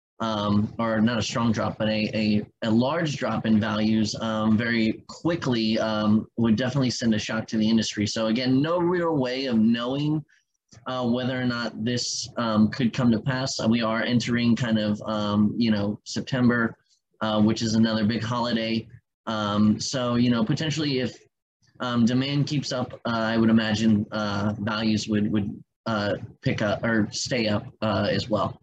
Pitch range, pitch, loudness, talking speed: 110-125 Hz, 115 Hz, -24 LUFS, 180 wpm